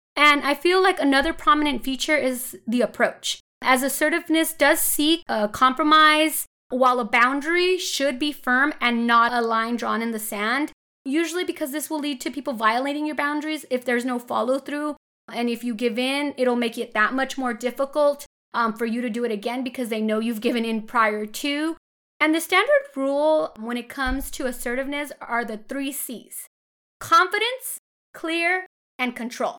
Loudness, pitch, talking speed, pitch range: -22 LUFS, 270 Hz, 180 wpm, 240-300 Hz